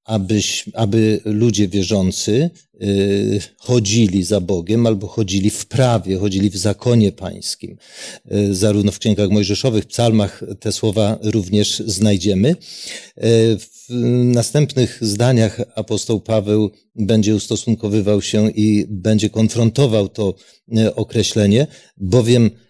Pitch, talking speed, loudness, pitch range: 110 Hz, 115 wpm, -17 LUFS, 105-115 Hz